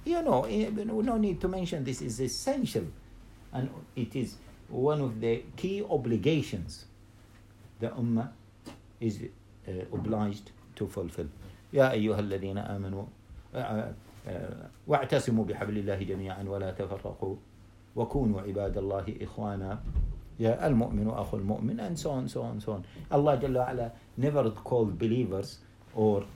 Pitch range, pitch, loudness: 100-125 Hz, 110 Hz, -32 LUFS